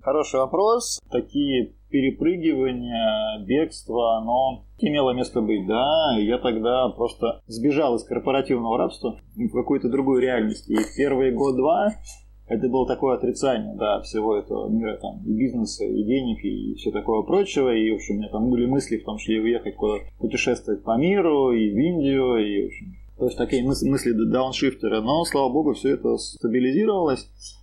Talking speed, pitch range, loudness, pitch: 165 wpm, 115-155 Hz, -23 LUFS, 130 Hz